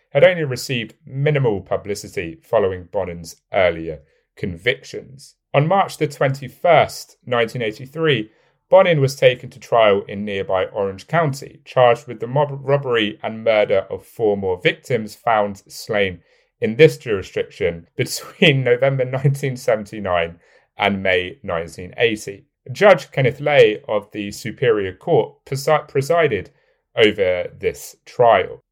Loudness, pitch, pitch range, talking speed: -19 LUFS, 130 Hz, 105-160 Hz, 120 wpm